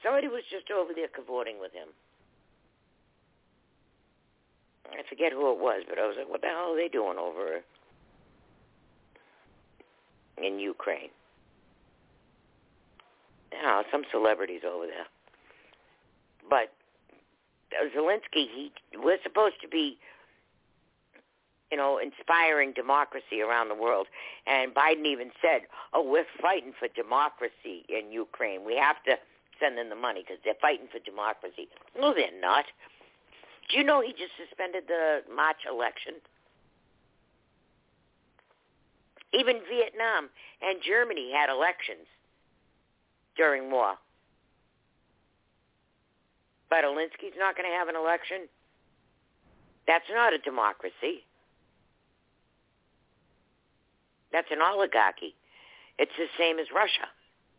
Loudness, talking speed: -29 LUFS, 115 wpm